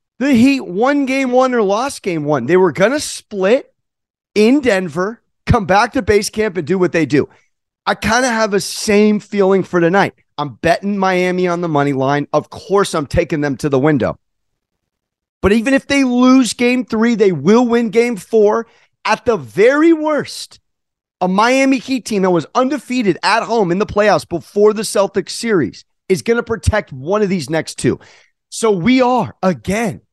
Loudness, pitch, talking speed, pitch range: -15 LUFS, 205 Hz, 190 wpm, 175-235 Hz